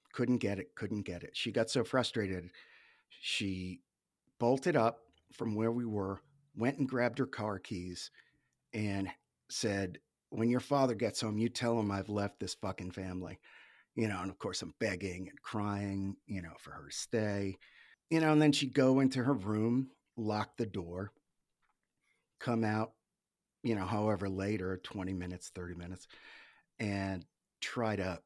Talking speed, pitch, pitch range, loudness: 165 wpm, 105 Hz, 95-120 Hz, -36 LUFS